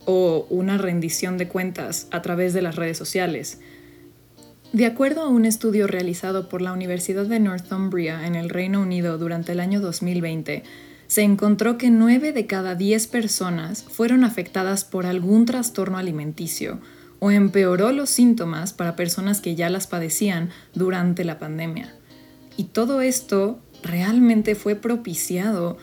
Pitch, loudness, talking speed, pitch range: 185 Hz, -22 LUFS, 145 wpm, 170-210 Hz